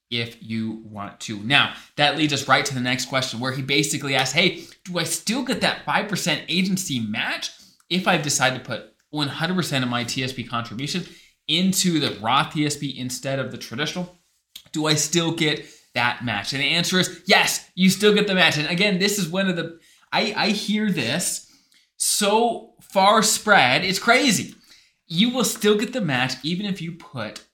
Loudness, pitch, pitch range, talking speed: -21 LUFS, 160 Hz, 130-185 Hz, 195 wpm